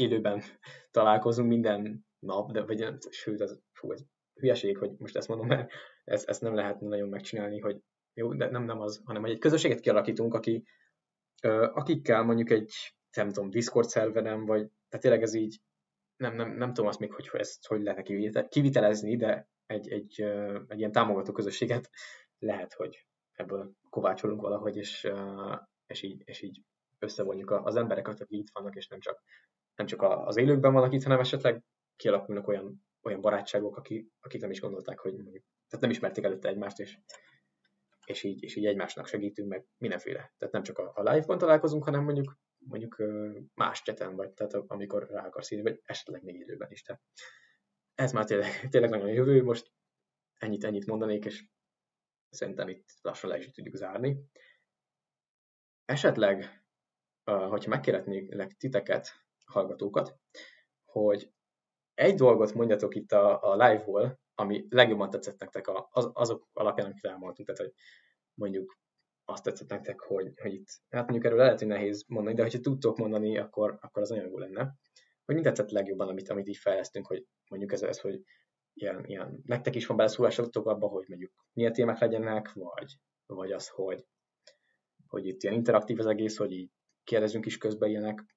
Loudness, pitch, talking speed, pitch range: -31 LUFS, 110 Hz, 165 wpm, 105-120 Hz